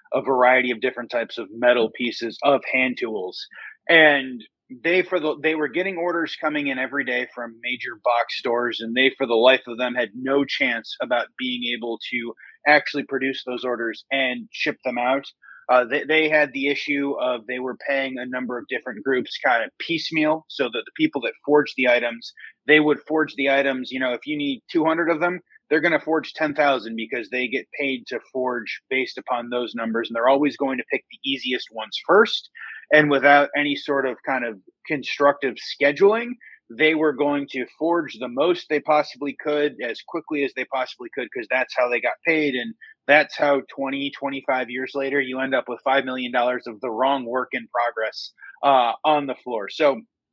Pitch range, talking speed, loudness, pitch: 125-150 Hz, 200 wpm, -22 LUFS, 135 Hz